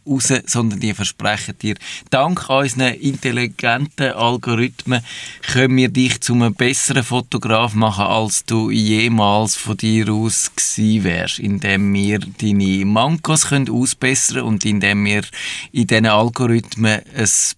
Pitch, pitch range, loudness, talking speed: 115 Hz, 105-130 Hz, -16 LUFS, 125 wpm